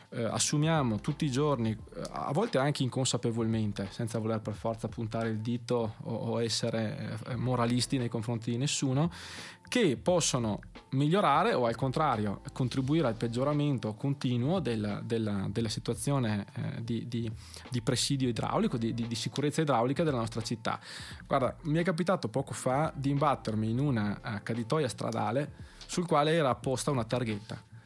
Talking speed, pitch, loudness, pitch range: 145 wpm, 120 Hz, -31 LUFS, 115-140 Hz